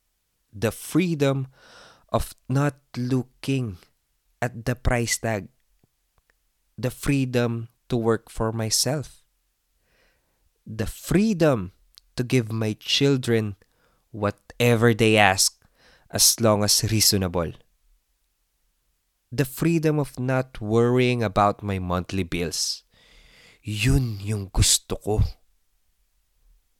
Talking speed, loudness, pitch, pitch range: 90 wpm, -23 LUFS, 110 Hz, 95-125 Hz